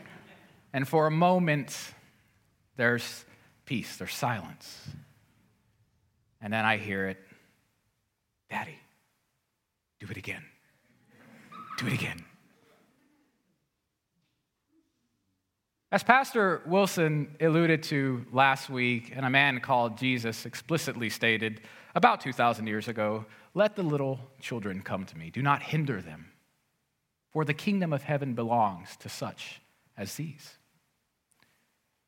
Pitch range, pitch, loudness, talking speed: 110-155 Hz, 130 Hz, -29 LUFS, 110 wpm